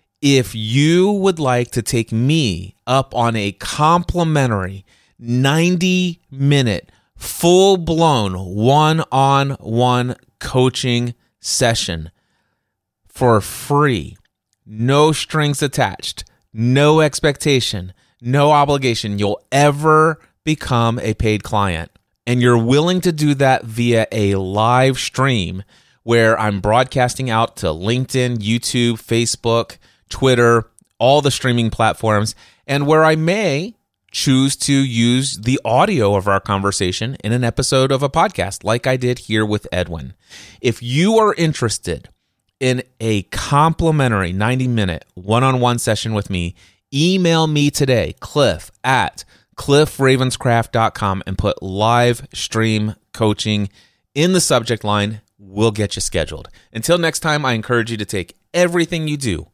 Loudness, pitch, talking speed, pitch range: -16 LUFS, 120 Hz, 125 wpm, 105-140 Hz